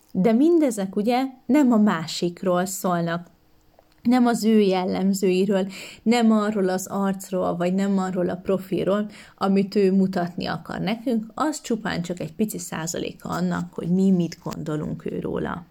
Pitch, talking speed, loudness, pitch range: 195 Hz, 145 wpm, -23 LUFS, 180-220 Hz